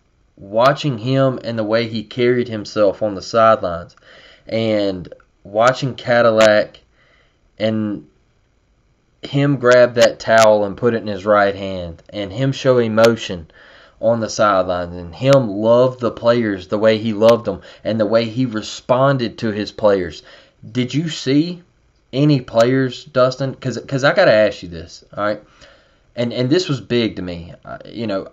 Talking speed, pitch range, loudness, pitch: 165 wpm, 105-125 Hz, -17 LUFS, 115 Hz